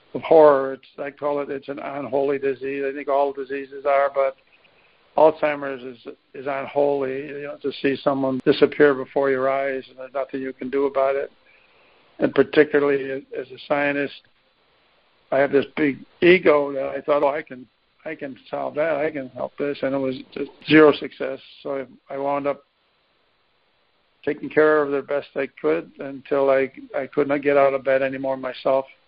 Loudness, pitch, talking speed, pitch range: -22 LUFS, 140 Hz, 180 wpm, 135-145 Hz